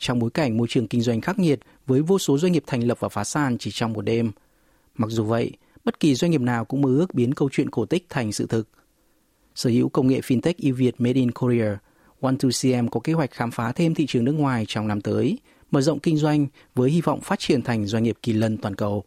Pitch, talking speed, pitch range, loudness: 125 Hz, 265 wpm, 115-150 Hz, -23 LUFS